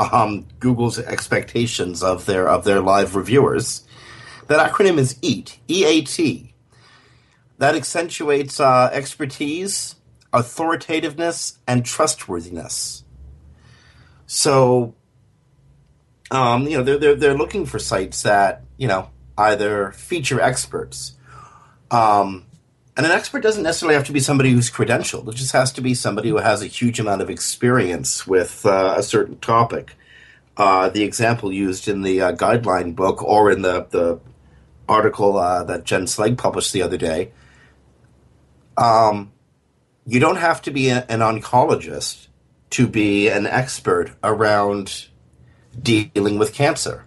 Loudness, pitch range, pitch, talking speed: -18 LUFS, 95-135 Hz, 120 Hz, 135 wpm